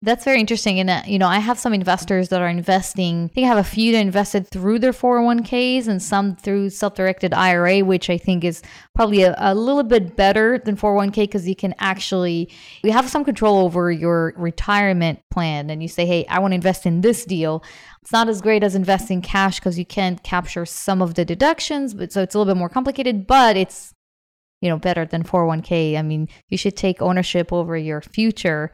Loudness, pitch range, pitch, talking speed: -19 LUFS, 175-210 Hz, 190 Hz, 215 wpm